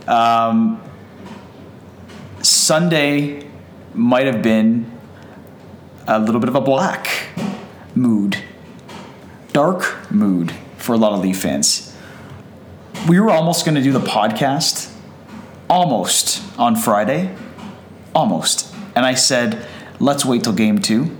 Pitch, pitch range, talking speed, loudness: 115 Hz, 110-145 Hz, 115 wpm, -16 LUFS